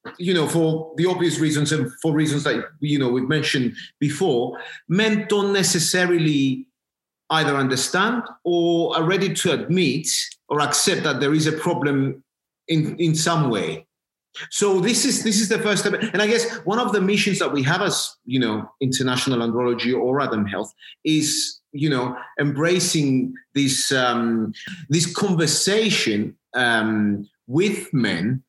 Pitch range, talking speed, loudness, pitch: 135-190 Hz, 155 wpm, -21 LUFS, 155 Hz